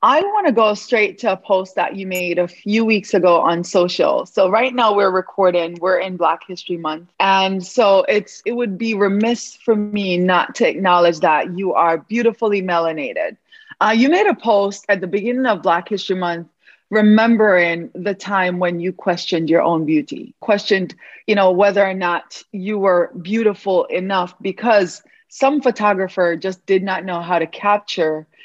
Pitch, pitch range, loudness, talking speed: 195 Hz, 180-215 Hz, -17 LUFS, 180 wpm